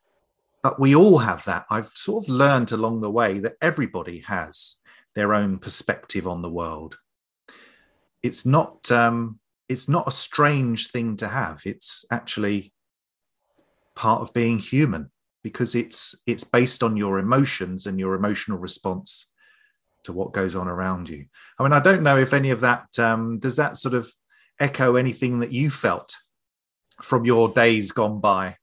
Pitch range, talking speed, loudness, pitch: 100-130 Hz, 165 wpm, -22 LUFS, 115 Hz